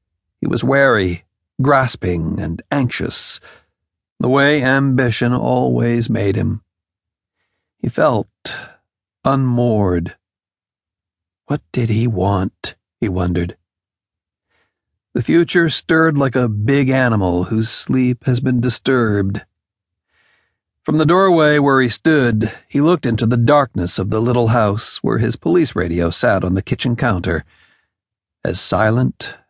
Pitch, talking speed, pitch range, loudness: 110 Hz, 120 wpm, 95-130 Hz, -16 LUFS